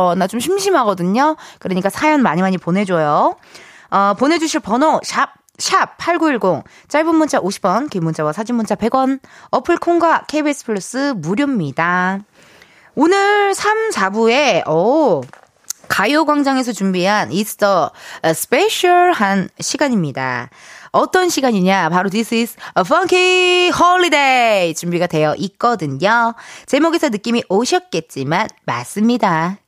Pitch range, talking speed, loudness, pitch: 185-315 Hz, 285 characters per minute, -15 LUFS, 235 Hz